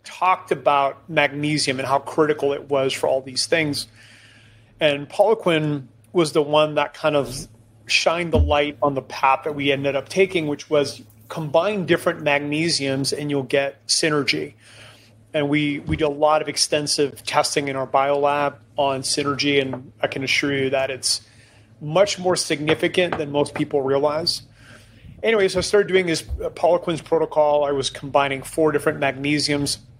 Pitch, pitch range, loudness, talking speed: 145 Hz, 130-155 Hz, -21 LUFS, 170 wpm